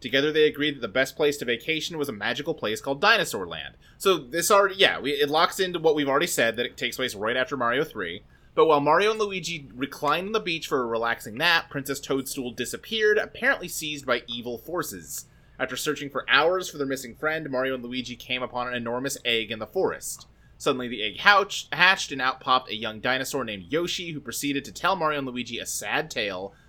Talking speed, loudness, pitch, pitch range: 220 wpm, -25 LUFS, 140 Hz, 125-165 Hz